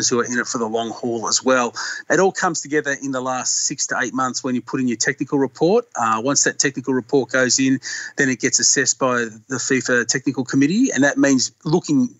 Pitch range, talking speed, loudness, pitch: 125-145 Hz, 235 wpm, -19 LUFS, 135 Hz